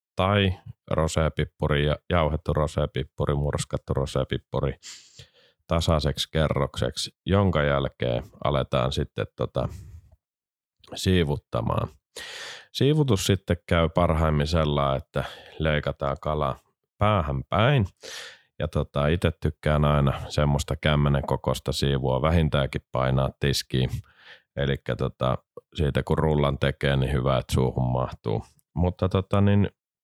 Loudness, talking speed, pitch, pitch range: -25 LUFS, 100 wpm, 75 Hz, 70-85 Hz